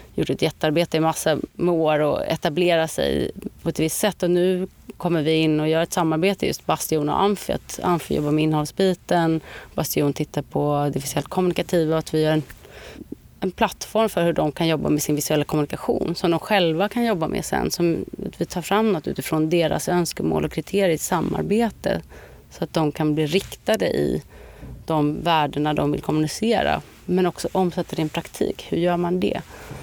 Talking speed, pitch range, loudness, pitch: 195 wpm, 155-185 Hz, -22 LUFS, 165 Hz